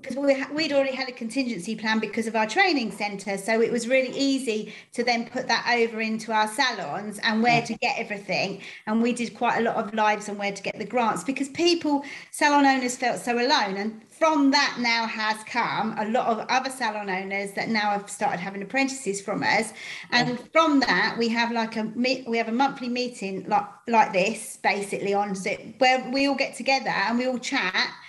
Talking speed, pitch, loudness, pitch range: 215 wpm, 230 Hz, -24 LUFS, 215-260 Hz